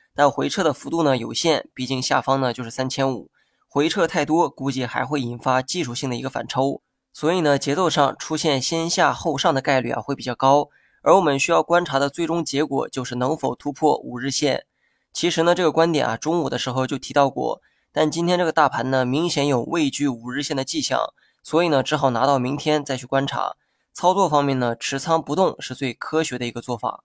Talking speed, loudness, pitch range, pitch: 320 characters per minute, -21 LUFS, 130-160 Hz, 140 Hz